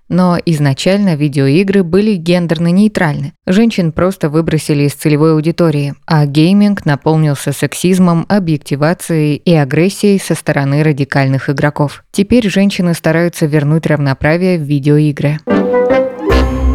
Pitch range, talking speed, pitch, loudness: 145-185 Hz, 110 wpm, 160 Hz, -12 LUFS